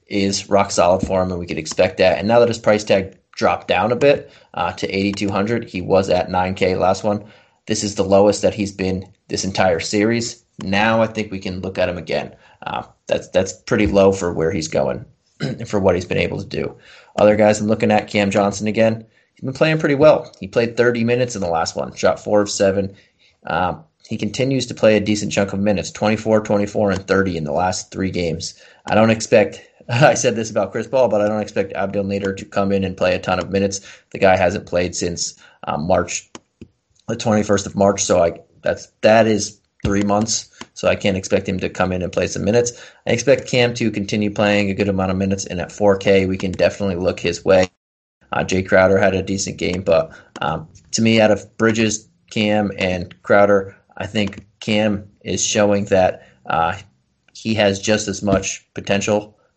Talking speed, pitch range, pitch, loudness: 215 wpm, 95-105 Hz, 100 Hz, -18 LUFS